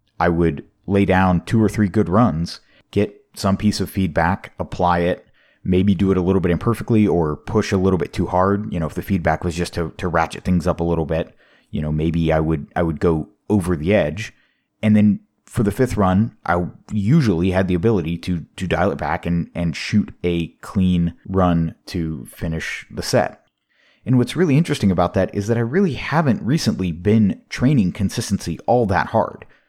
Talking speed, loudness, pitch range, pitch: 200 wpm, -20 LUFS, 85-105 Hz, 95 Hz